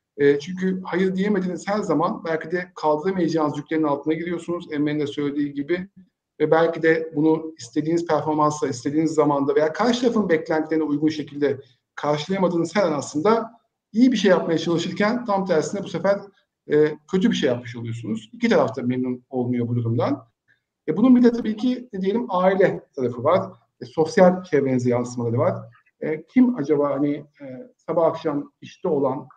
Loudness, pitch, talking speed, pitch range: -22 LUFS, 160 Hz, 155 wpm, 145-190 Hz